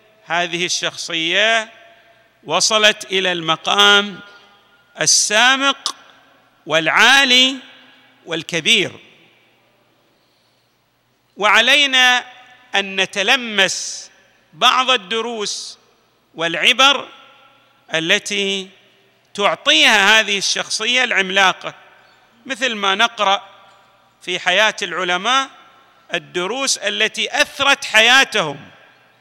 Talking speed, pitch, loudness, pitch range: 60 wpm, 210 Hz, -14 LUFS, 190-250 Hz